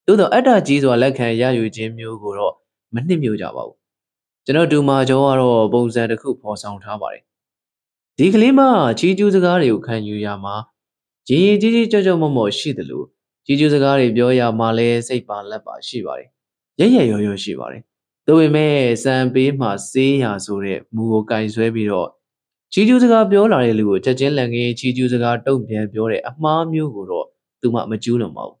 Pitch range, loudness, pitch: 110-150 Hz, -16 LUFS, 125 Hz